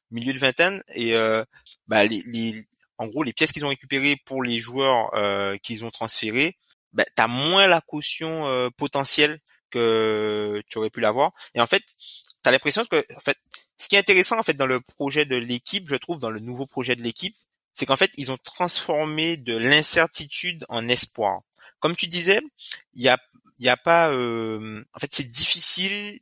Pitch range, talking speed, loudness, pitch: 115-165 Hz, 200 wpm, -22 LUFS, 135 Hz